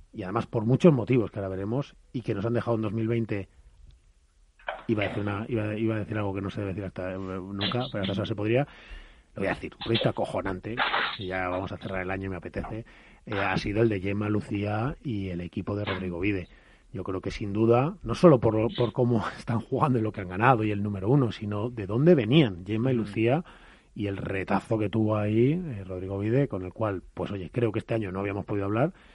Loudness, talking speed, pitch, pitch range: -28 LUFS, 235 wpm, 105 Hz, 95-115 Hz